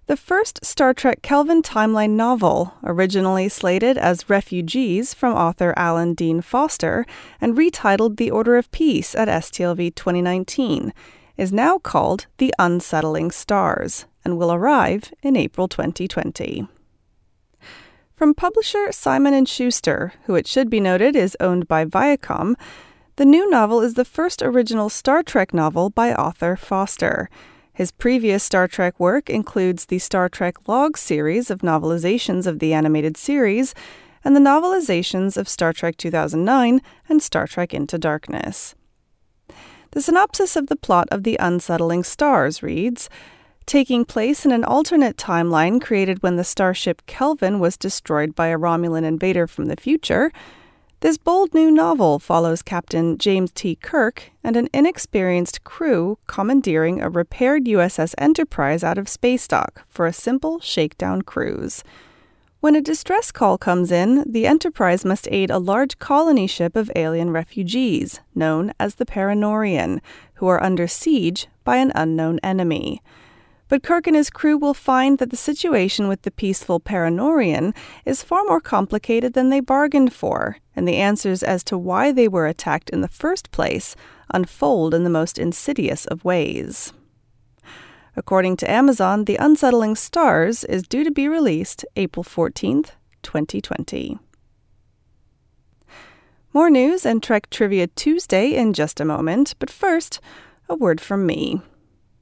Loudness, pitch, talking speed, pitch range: -19 LUFS, 205 Hz, 145 wpm, 175-275 Hz